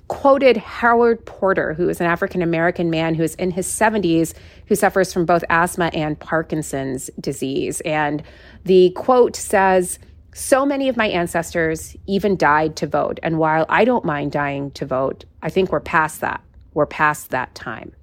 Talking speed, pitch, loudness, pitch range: 175 wpm, 170 Hz, -19 LUFS, 155-195 Hz